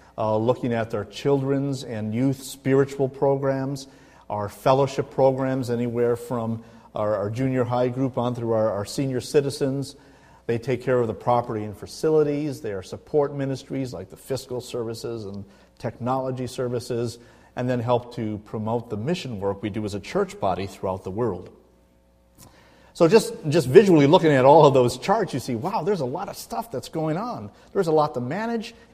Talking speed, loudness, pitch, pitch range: 190 wpm, -23 LUFS, 125 Hz, 115-140 Hz